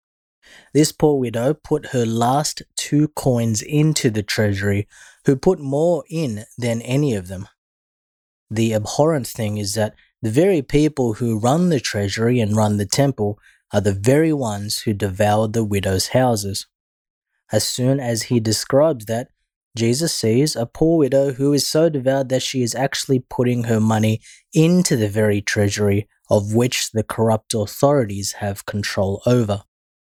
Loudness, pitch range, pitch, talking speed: -19 LUFS, 105-140 Hz, 120 Hz, 155 wpm